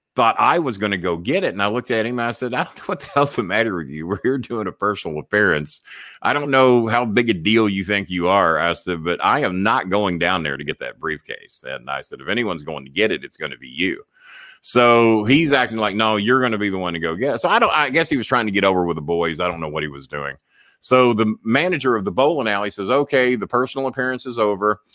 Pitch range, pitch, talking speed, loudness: 90-125 Hz, 110 Hz, 290 wpm, -19 LUFS